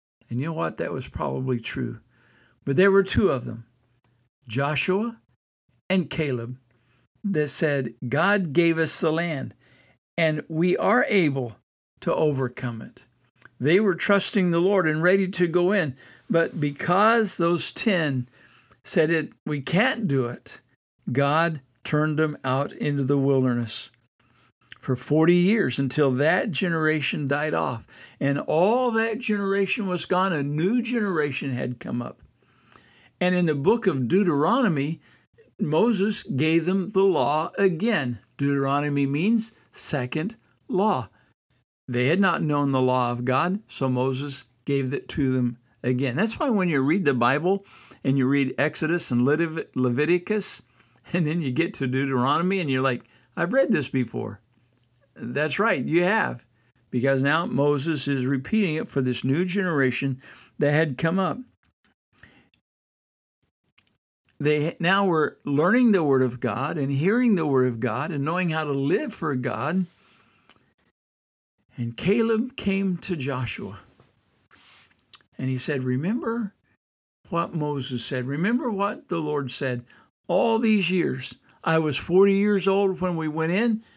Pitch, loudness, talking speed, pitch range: 150 Hz, -24 LUFS, 145 wpm, 130-185 Hz